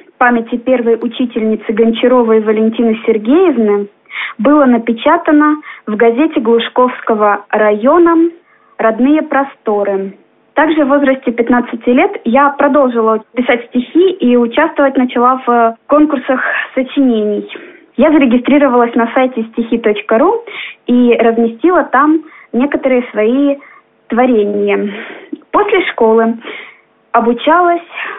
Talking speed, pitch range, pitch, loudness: 90 wpm, 230-295 Hz, 250 Hz, -11 LUFS